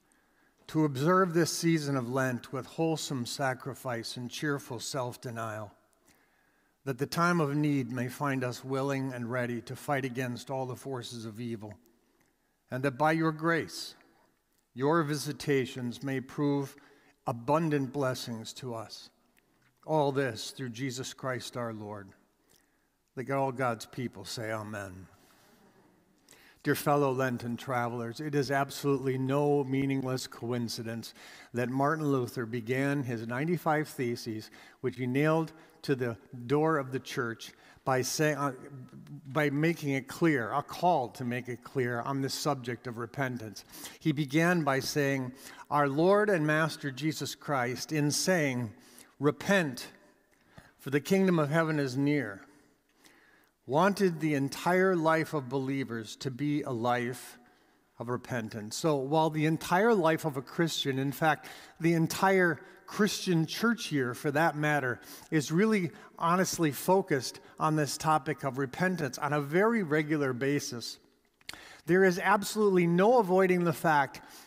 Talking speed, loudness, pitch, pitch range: 140 wpm, -30 LUFS, 140 Hz, 125-155 Hz